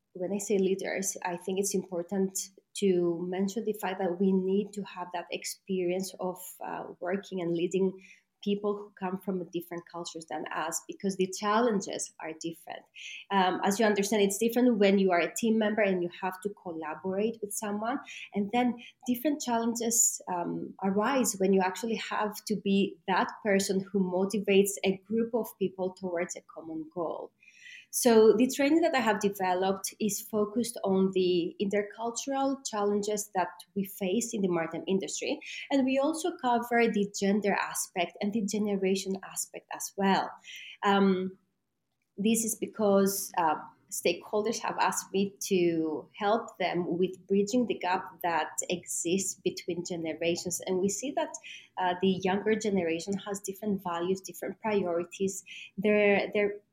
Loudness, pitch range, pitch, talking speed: -30 LUFS, 185-215 Hz, 195 Hz, 155 wpm